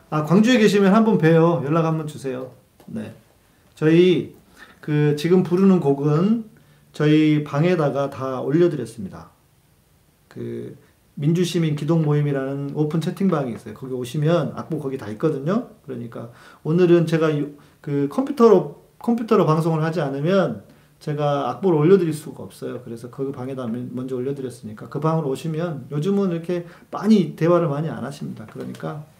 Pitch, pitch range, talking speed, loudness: 155 Hz, 135-175 Hz, 335 characters per minute, -20 LUFS